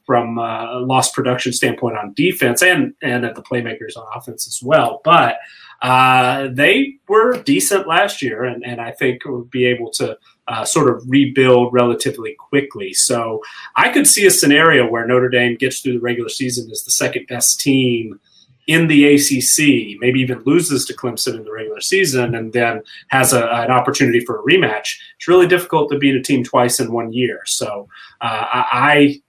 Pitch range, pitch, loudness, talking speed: 120-155 Hz, 130 Hz, -15 LUFS, 190 wpm